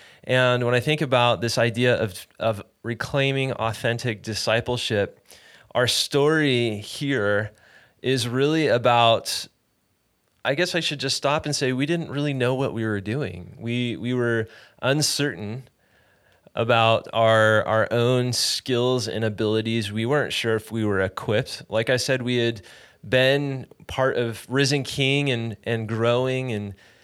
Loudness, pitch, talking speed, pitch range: -23 LUFS, 120 Hz, 145 wpm, 110-135 Hz